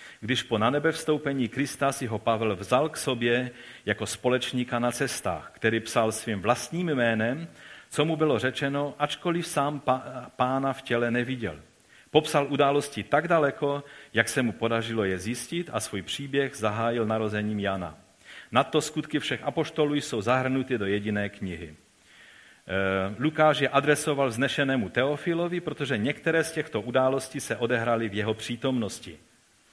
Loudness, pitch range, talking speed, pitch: -27 LUFS, 115-145 Hz, 145 wpm, 130 Hz